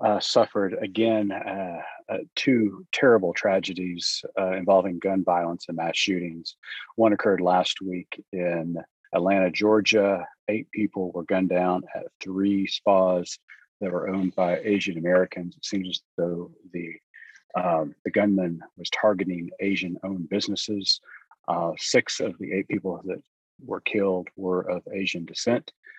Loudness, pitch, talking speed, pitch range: -25 LUFS, 95 Hz, 145 wpm, 90-100 Hz